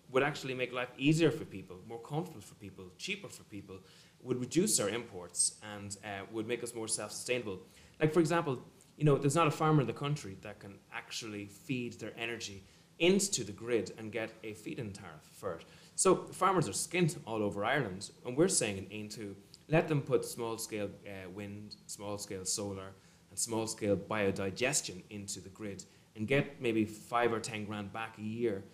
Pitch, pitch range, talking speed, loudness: 110 Hz, 100-140 Hz, 190 wpm, -34 LUFS